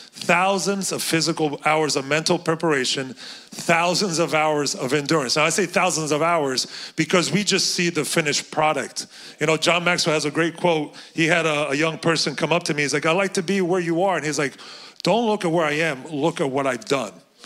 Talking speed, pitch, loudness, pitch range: 225 wpm, 165 Hz, -21 LUFS, 155-180 Hz